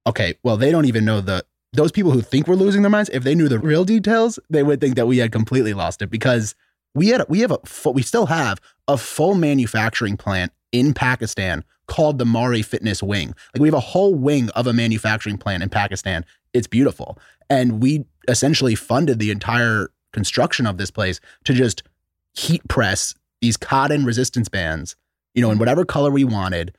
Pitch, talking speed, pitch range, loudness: 120 Hz, 200 wpm, 105-140 Hz, -19 LUFS